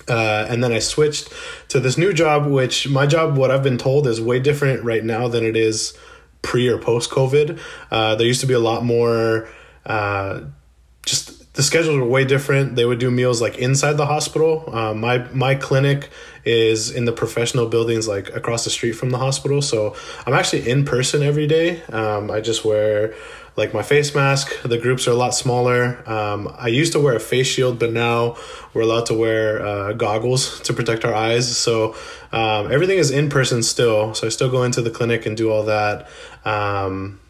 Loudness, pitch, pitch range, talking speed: -19 LUFS, 120 Hz, 110-135 Hz, 205 wpm